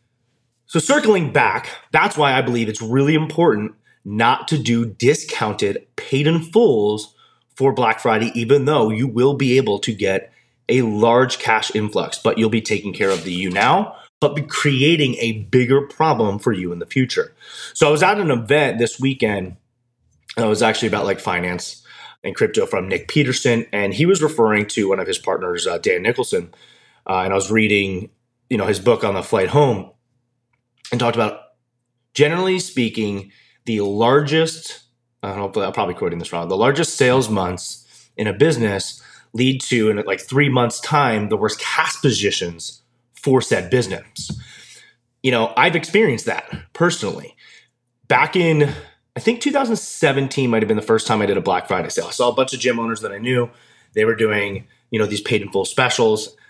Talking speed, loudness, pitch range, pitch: 180 wpm, -18 LUFS, 110-145 Hz, 120 Hz